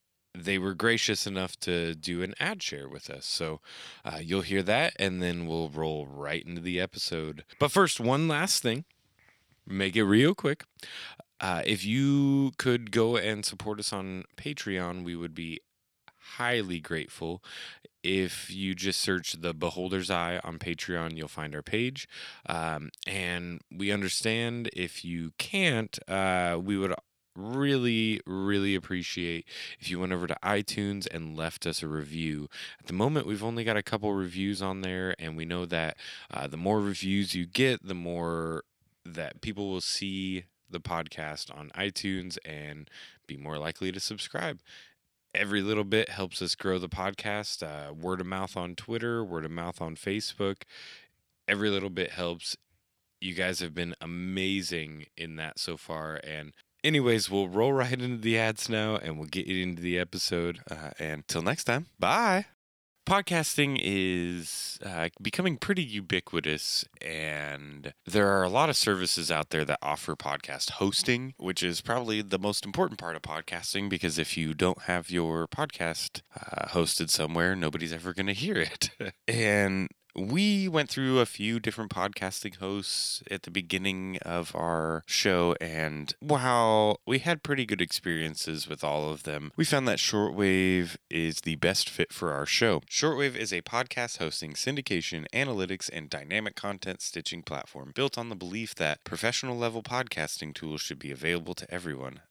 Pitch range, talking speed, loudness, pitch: 85-105 Hz, 165 wpm, -30 LUFS, 95 Hz